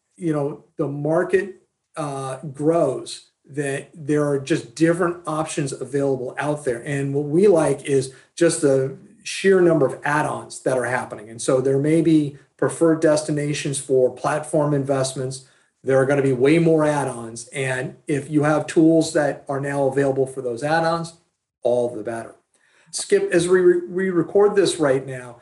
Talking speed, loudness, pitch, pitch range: 170 wpm, -21 LUFS, 145 Hz, 135-165 Hz